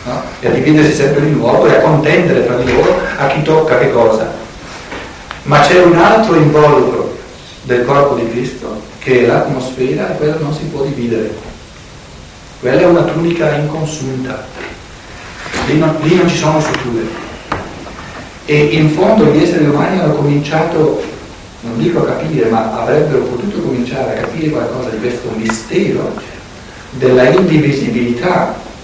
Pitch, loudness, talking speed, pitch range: 150 Hz, -12 LUFS, 150 wpm, 130-160 Hz